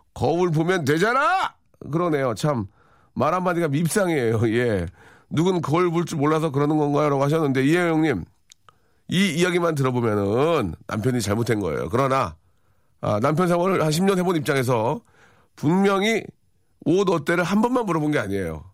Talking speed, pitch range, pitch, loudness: 330 characters per minute, 115-175 Hz, 150 Hz, -22 LUFS